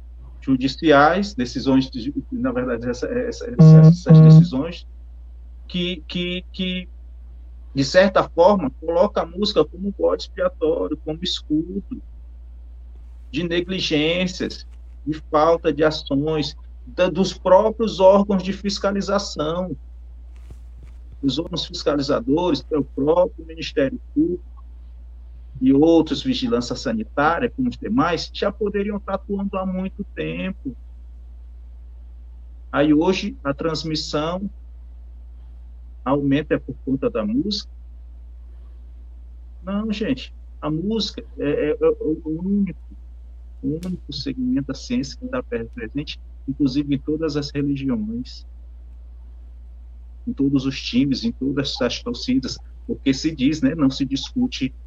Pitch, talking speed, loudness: 150 Hz, 115 wpm, -20 LUFS